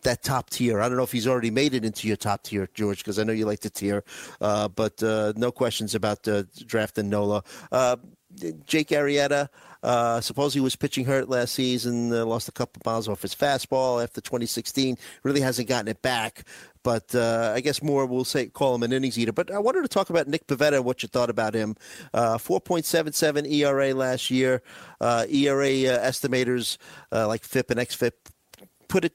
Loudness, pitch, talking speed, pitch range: -25 LUFS, 125 Hz, 210 wpm, 110-140 Hz